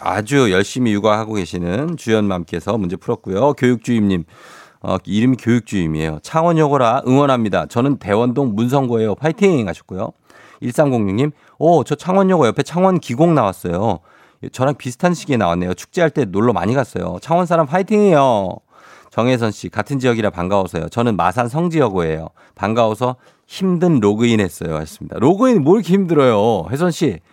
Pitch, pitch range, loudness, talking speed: 120 Hz, 100-155 Hz, -17 LUFS, 375 characters per minute